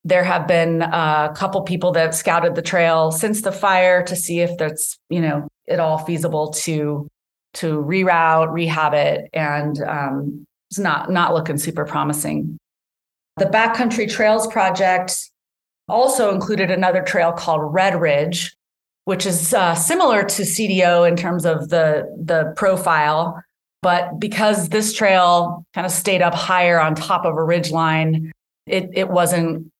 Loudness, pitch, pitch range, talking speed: -18 LUFS, 170 Hz, 160-185 Hz, 155 wpm